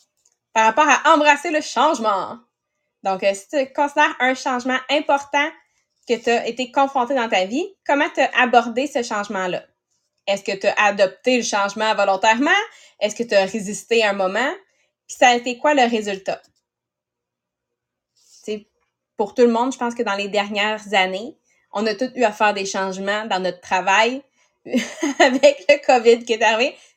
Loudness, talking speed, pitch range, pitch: -19 LUFS, 175 wpm, 200-275 Hz, 230 Hz